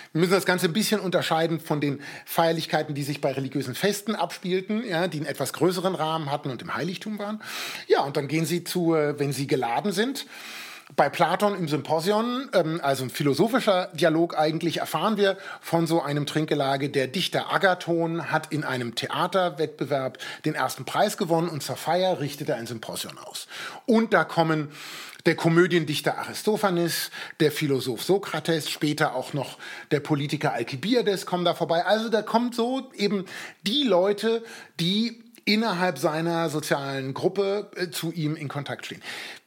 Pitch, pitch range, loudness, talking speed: 165 Hz, 150-195 Hz, -25 LUFS, 160 wpm